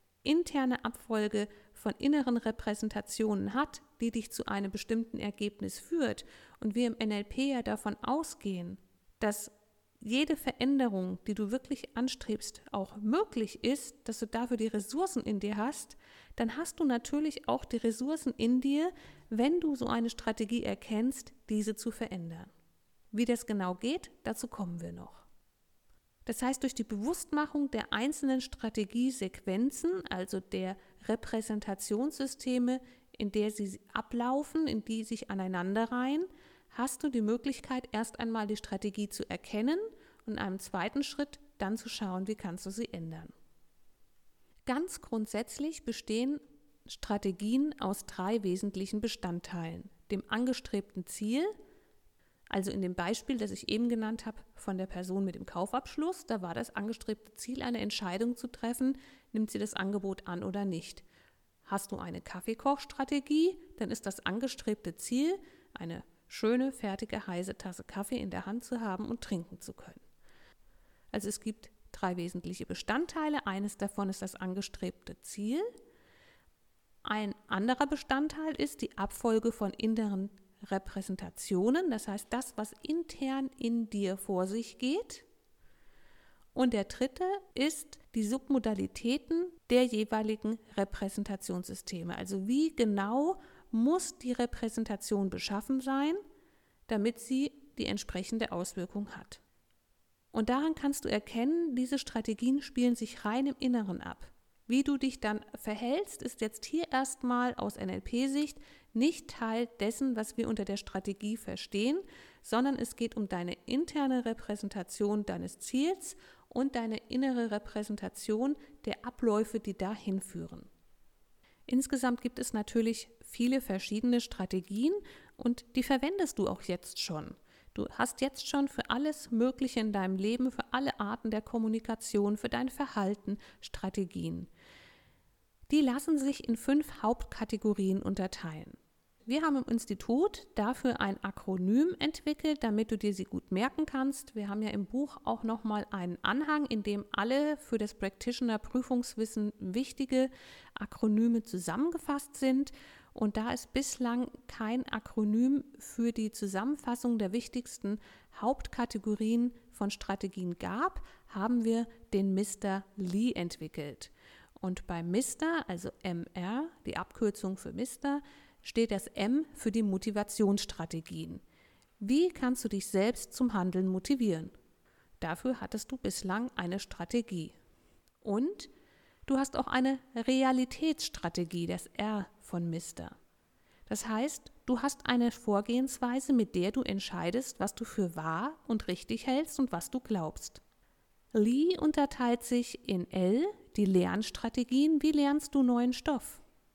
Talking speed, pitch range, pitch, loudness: 135 wpm, 200-265 Hz, 230 Hz, -34 LUFS